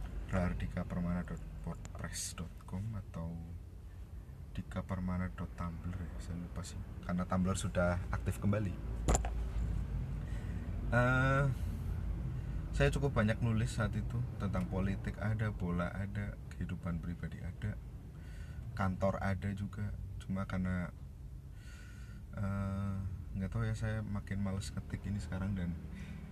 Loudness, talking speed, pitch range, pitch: -38 LUFS, 100 wpm, 85-100 Hz, 95 Hz